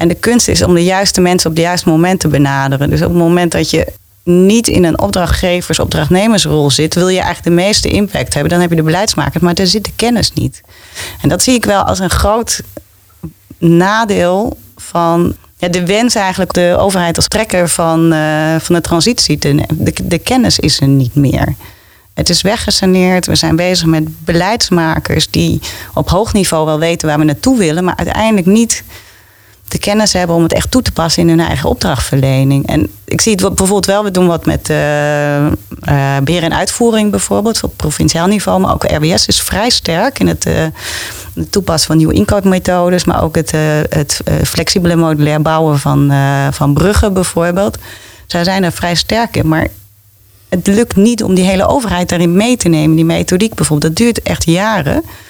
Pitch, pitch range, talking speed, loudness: 170 Hz, 150-190 Hz, 195 wpm, -11 LUFS